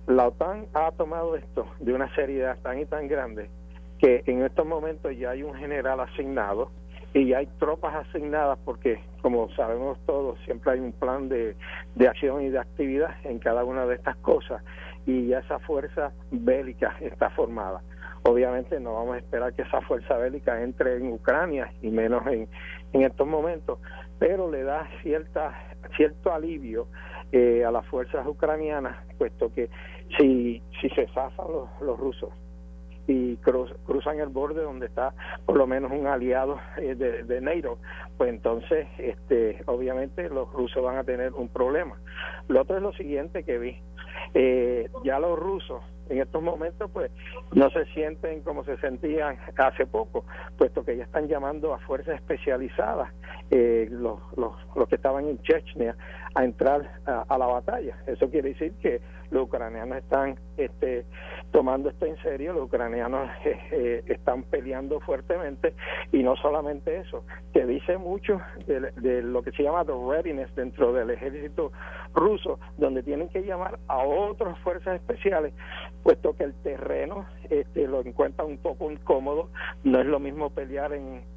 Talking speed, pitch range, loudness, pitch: 165 wpm, 120-170 Hz, -27 LUFS, 135 Hz